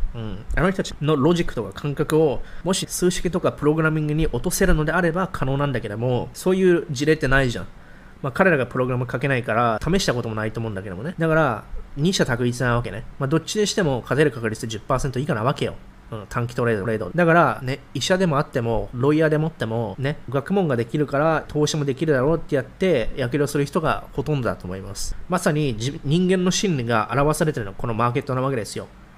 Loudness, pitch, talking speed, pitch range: -22 LUFS, 140 Hz, 465 characters per minute, 120-160 Hz